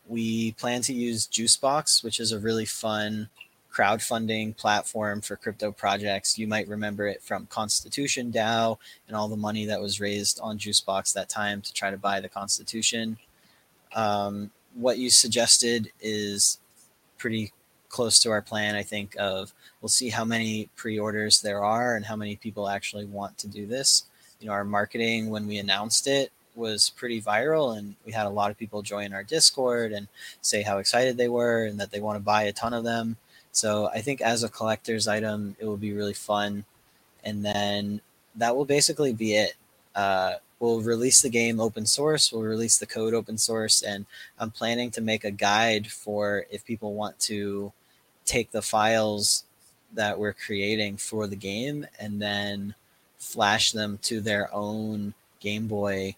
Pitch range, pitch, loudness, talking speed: 105-115 Hz, 110 Hz, -25 LUFS, 180 wpm